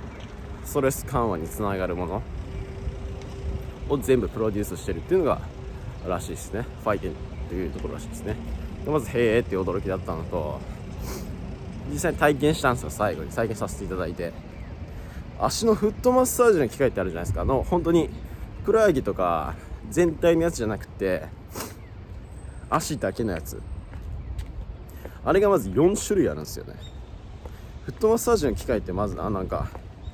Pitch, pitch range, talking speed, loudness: 95 Hz, 90-120 Hz, 350 characters per minute, -26 LUFS